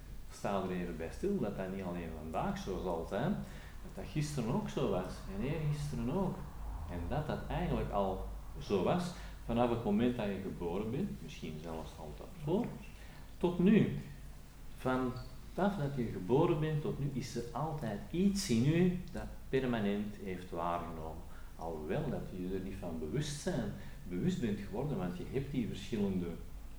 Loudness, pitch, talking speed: -37 LUFS, 100 Hz, 170 wpm